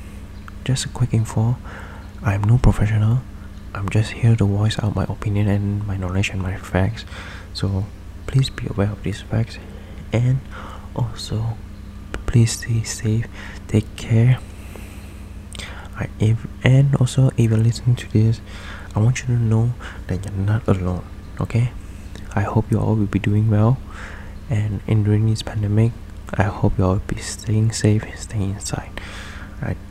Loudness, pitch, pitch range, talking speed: -21 LUFS, 100 Hz, 95-110 Hz, 160 wpm